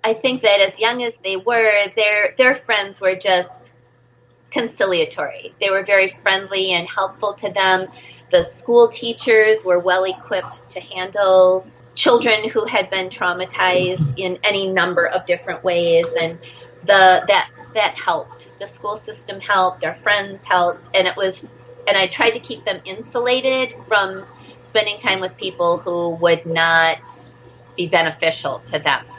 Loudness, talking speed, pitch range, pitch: -17 LUFS, 155 wpm, 175-210 Hz, 190 Hz